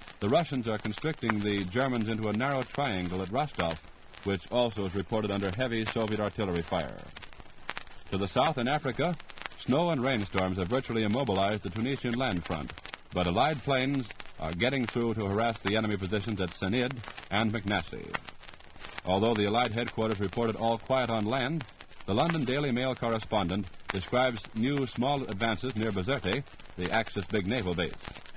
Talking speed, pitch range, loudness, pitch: 160 wpm, 100-125 Hz, -31 LUFS, 110 Hz